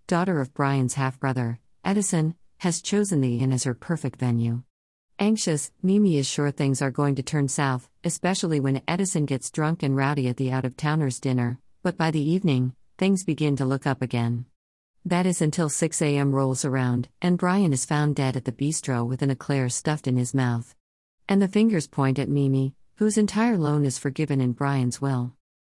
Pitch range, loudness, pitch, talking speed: 130-165 Hz, -25 LUFS, 140 Hz, 195 wpm